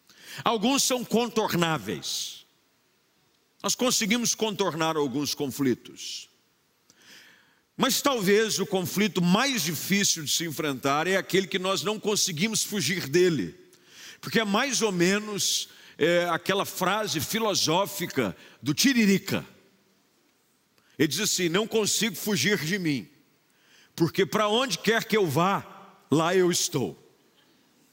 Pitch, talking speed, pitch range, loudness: 195 Hz, 115 wpm, 165-215 Hz, -25 LUFS